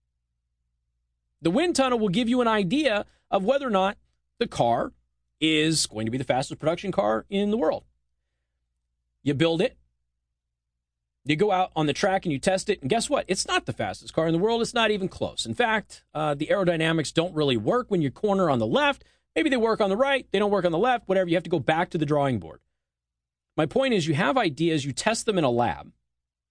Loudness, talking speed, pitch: -25 LUFS, 230 wpm, 160 Hz